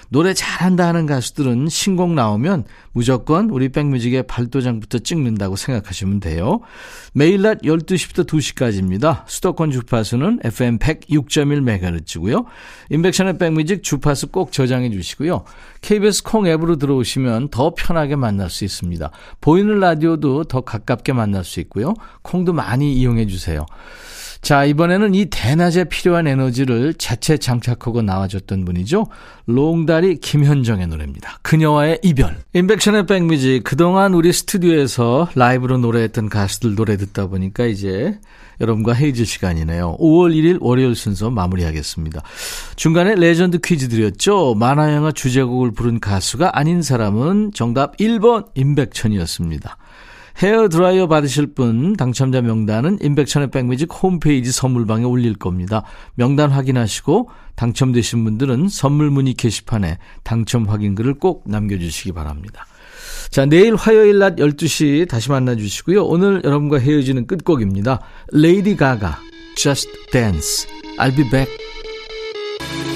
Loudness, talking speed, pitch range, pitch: -16 LUFS, 340 characters per minute, 115-170 Hz, 135 Hz